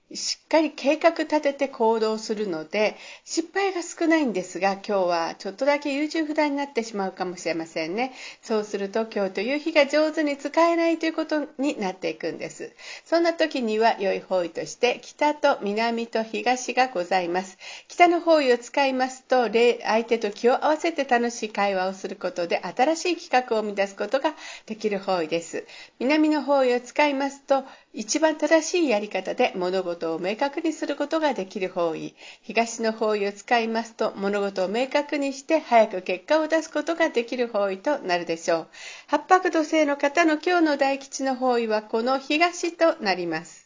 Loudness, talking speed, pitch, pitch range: -24 LUFS, 355 characters per minute, 250 Hz, 200-300 Hz